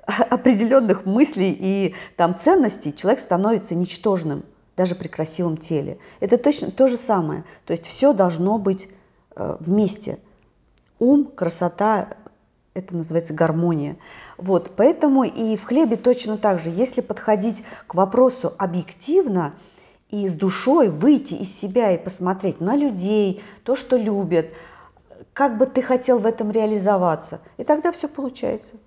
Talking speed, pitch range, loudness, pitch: 135 wpm, 180-250 Hz, -20 LUFS, 205 Hz